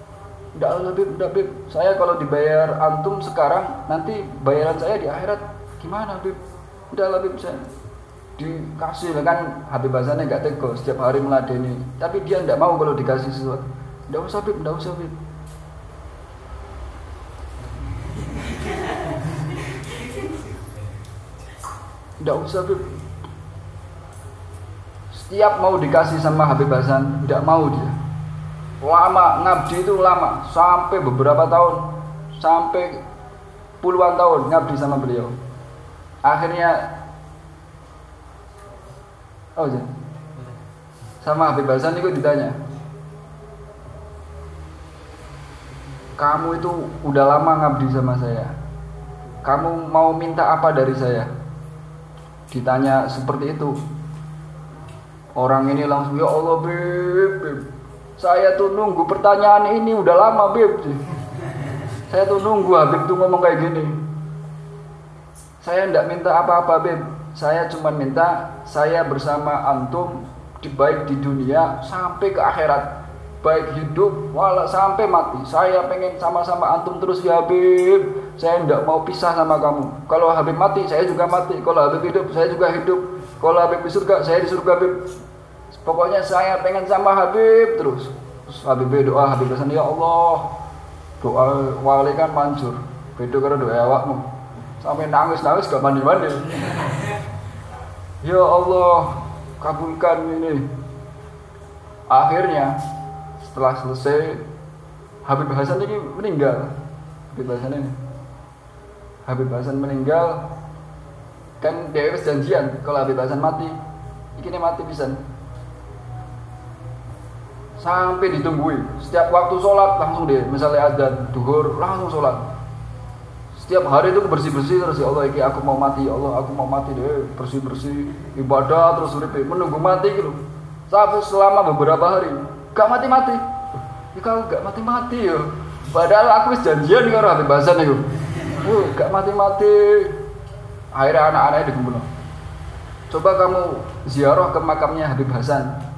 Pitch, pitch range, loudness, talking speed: 145 Hz, 130-170 Hz, -18 LUFS, 120 wpm